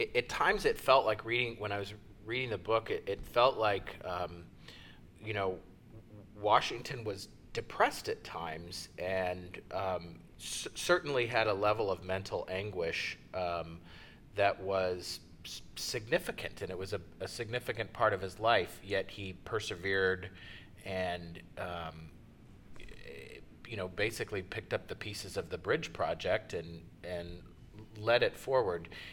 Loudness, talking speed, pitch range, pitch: -35 LUFS, 140 wpm, 85-110 Hz, 95 Hz